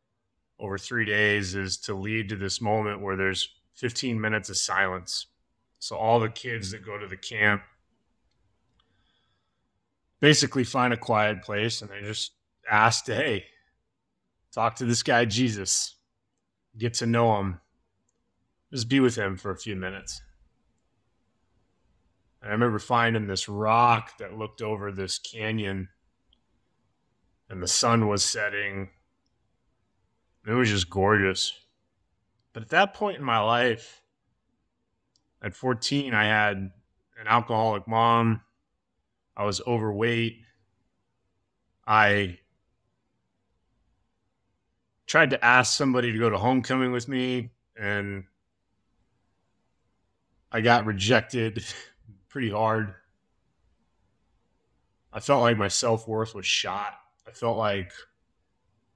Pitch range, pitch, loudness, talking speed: 95-115 Hz, 110 Hz, -25 LUFS, 120 wpm